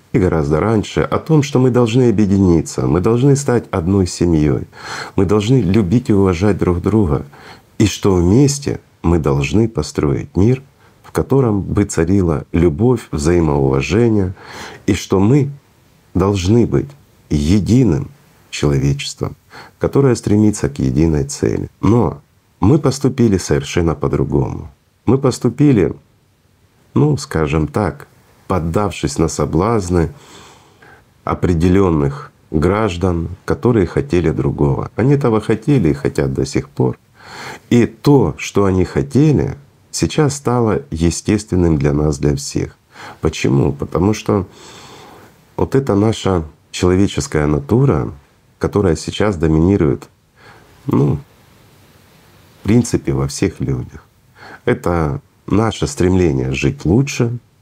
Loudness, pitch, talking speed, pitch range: -16 LUFS, 100 Hz, 110 wpm, 80-120 Hz